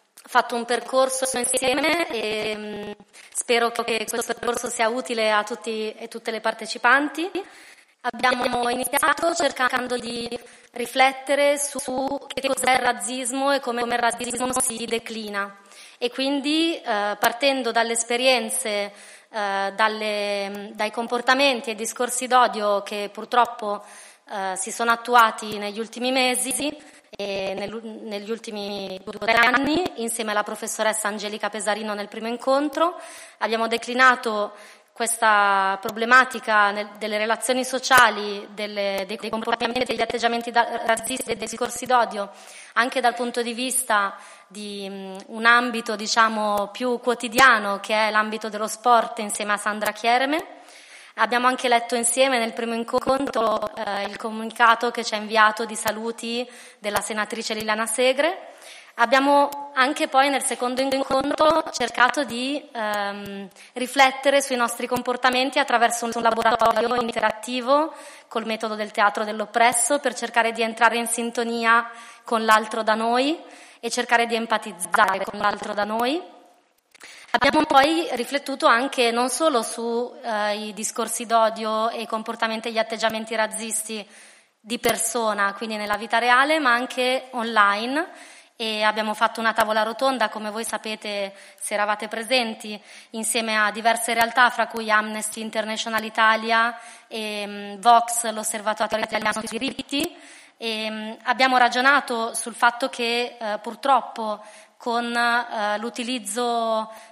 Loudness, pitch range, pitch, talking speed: -22 LUFS, 215-250 Hz, 230 Hz, 130 wpm